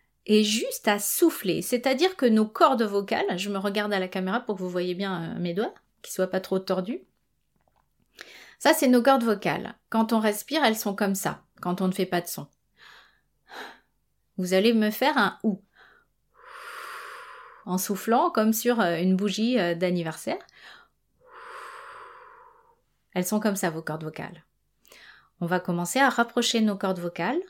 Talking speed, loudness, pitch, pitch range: 160 wpm, -25 LUFS, 210 Hz, 185-240 Hz